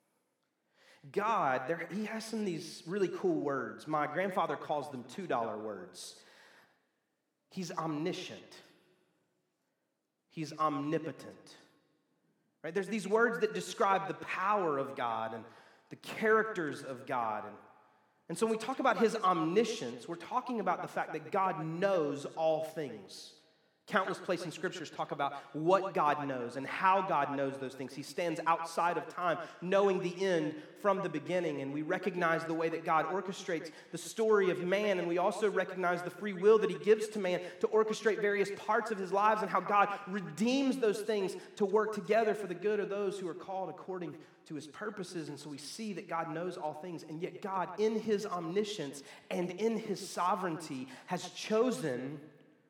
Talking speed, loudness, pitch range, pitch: 175 wpm, -34 LUFS, 160-210 Hz, 185 Hz